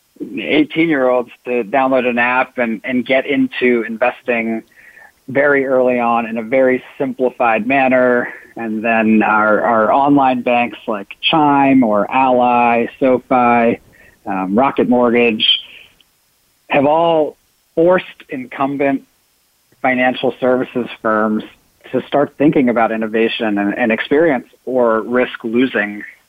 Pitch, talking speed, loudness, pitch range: 125 Hz, 115 wpm, -15 LUFS, 115-130 Hz